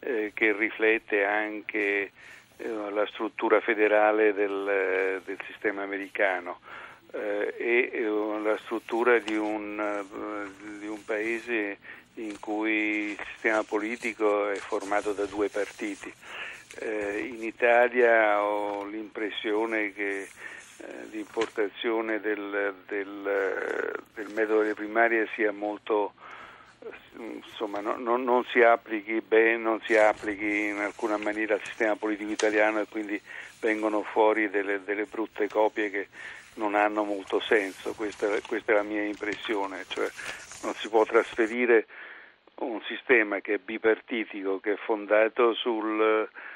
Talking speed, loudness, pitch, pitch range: 125 wpm, -27 LUFS, 105 Hz, 105-110 Hz